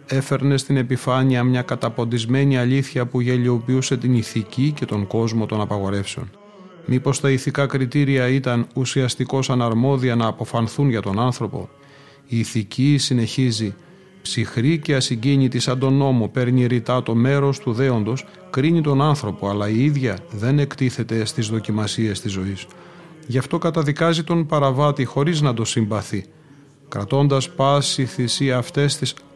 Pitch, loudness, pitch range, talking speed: 130 Hz, -20 LUFS, 115-140 Hz, 140 wpm